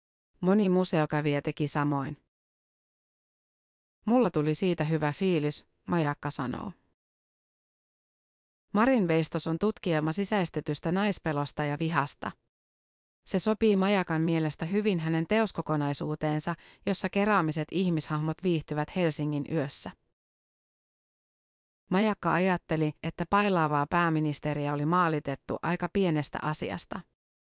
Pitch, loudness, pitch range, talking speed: 160 Hz, -28 LUFS, 150-185 Hz, 90 wpm